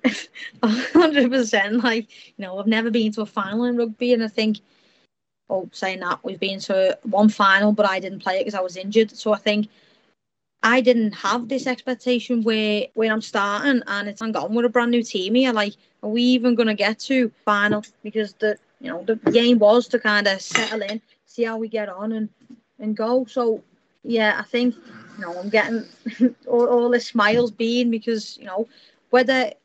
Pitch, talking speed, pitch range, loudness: 225 Hz, 200 wpm, 210-245 Hz, -21 LUFS